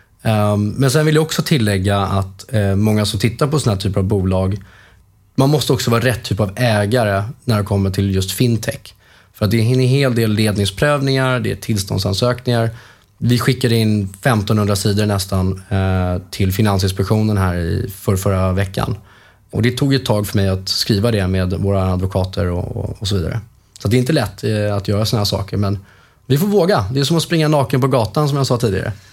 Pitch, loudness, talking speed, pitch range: 105 Hz, -17 LUFS, 195 wpm, 100-120 Hz